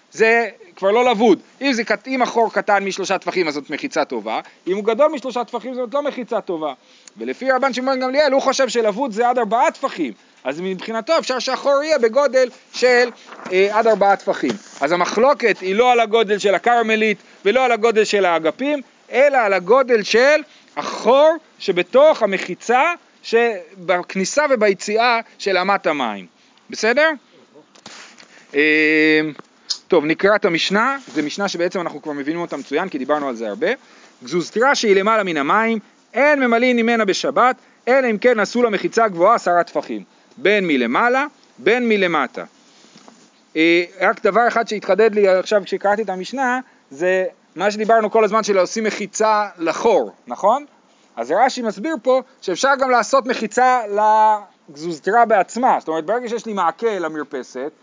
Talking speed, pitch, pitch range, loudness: 155 wpm, 225 Hz, 190-255 Hz, -18 LUFS